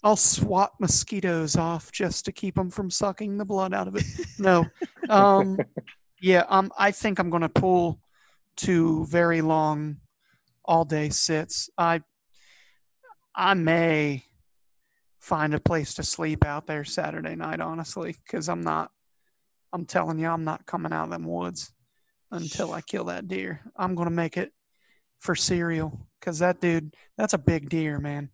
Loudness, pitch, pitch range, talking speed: -25 LUFS, 165 Hz, 150-185 Hz, 155 wpm